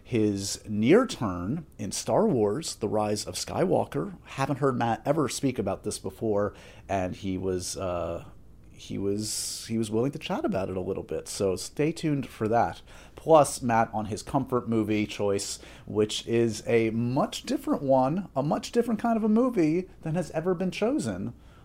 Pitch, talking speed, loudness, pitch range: 115 Hz, 175 wpm, -28 LUFS, 100-150 Hz